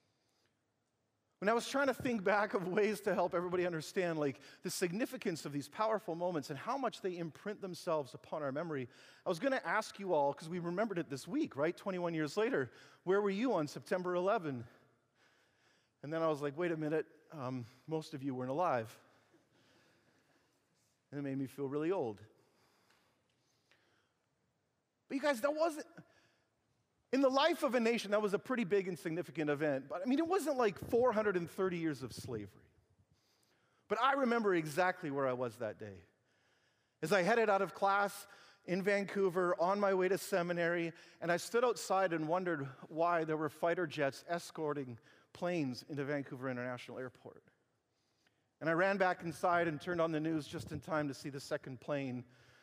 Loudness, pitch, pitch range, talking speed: -37 LUFS, 170 Hz, 145-200 Hz, 180 wpm